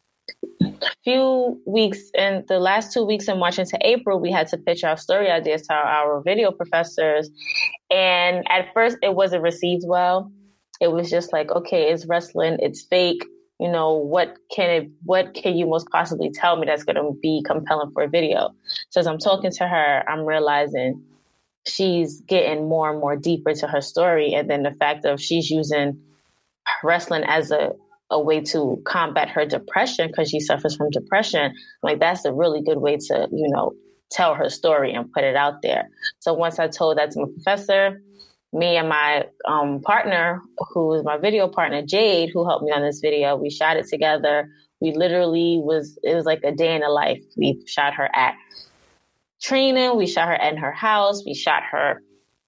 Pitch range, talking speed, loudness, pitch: 150-190 Hz, 195 wpm, -21 LUFS, 165 Hz